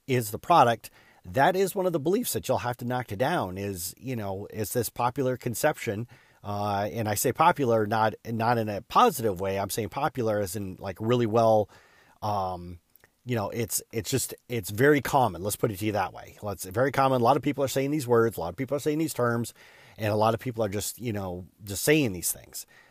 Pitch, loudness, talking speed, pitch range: 115 Hz, -27 LUFS, 240 wpm, 105-130 Hz